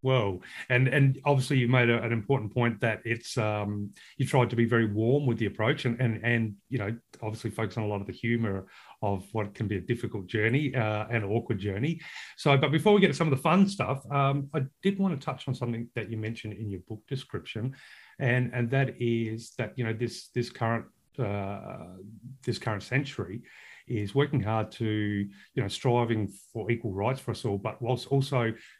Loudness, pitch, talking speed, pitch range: -29 LUFS, 120 Hz, 215 wpm, 110-130 Hz